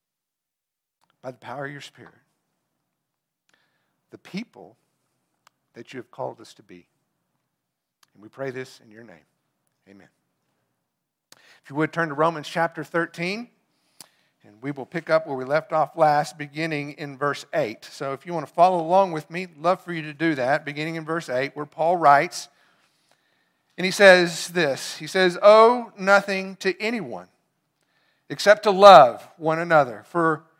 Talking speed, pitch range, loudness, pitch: 165 wpm, 145-180 Hz, -20 LUFS, 160 Hz